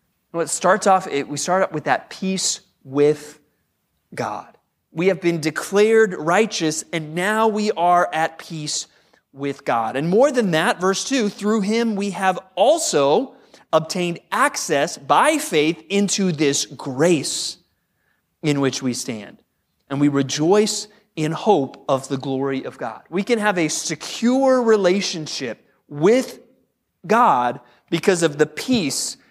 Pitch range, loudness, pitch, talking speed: 150-205 Hz, -20 LUFS, 175 Hz, 140 wpm